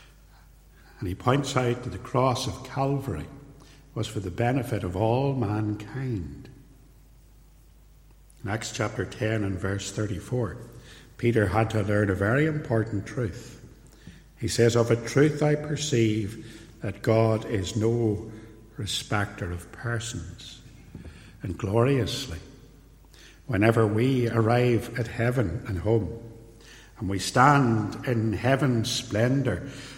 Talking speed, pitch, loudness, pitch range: 120 wpm, 115 Hz, -26 LUFS, 105-125 Hz